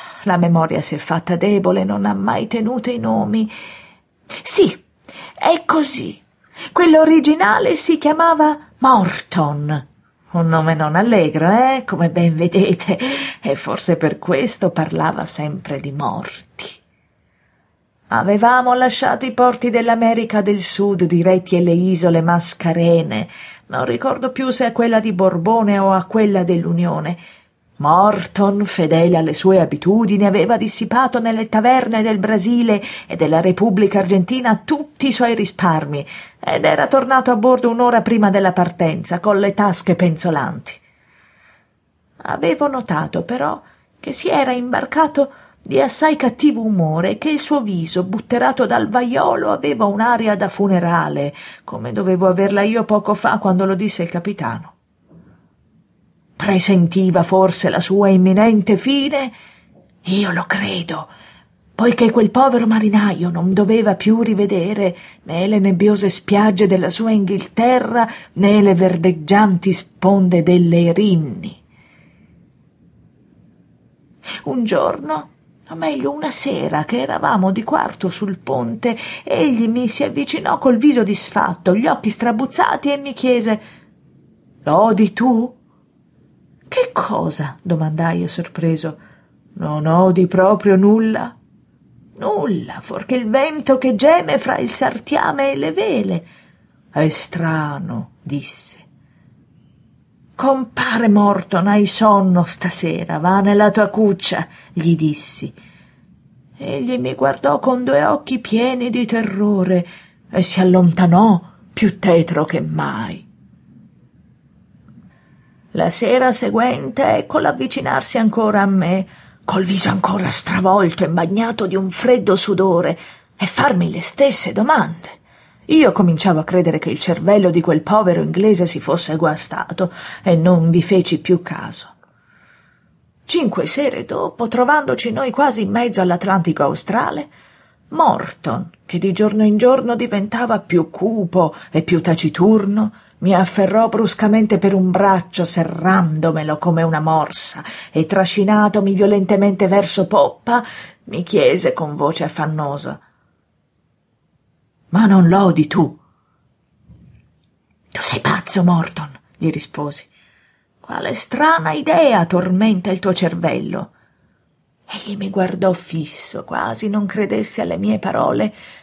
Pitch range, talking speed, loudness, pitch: 175-230 Hz, 125 wpm, -16 LUFS, 195 Hz